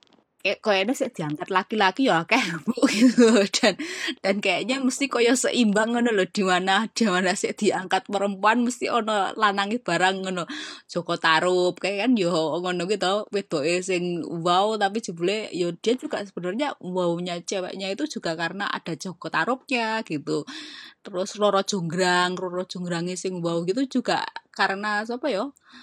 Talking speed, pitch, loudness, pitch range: 160 wpm, 195 Hz, -24 LUFS, 180-225 Hz